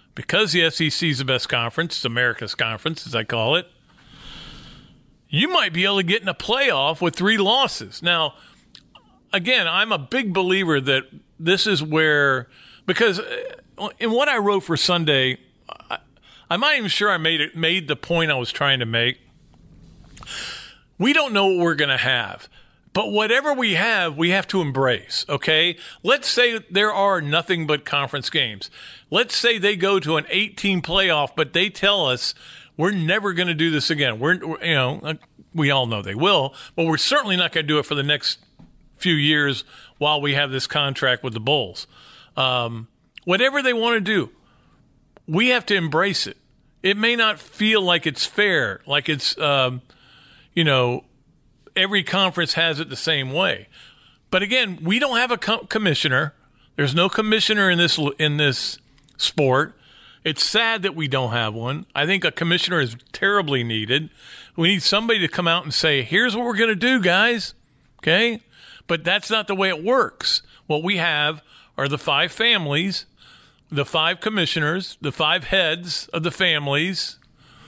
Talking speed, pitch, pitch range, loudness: 180 wpm, 165 Hz, 145-195 Hz, -20 LUFS